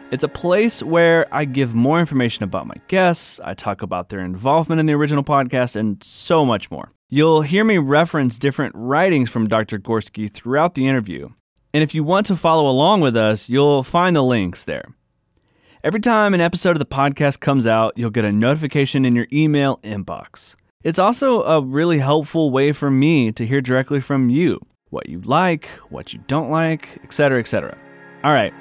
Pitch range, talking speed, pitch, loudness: 120-160 Hz, 195 wpm, 140 Hz, -18 LUFS